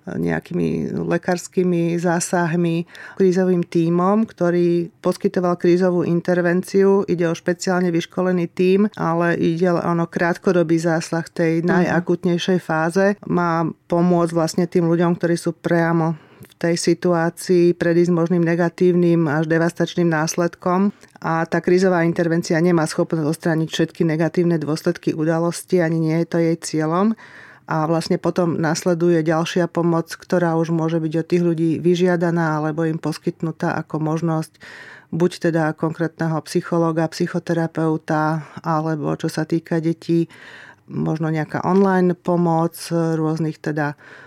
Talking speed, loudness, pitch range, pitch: 125 wpm, -19 LUFS, 165-175 Hz, 170 Hz